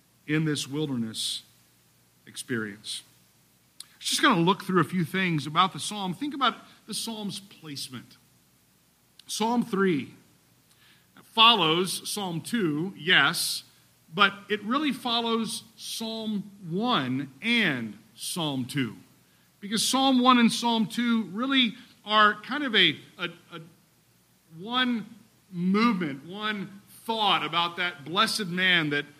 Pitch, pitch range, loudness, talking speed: 185 Hz, 150-225 Hz, -26 LUFS, 120 wpm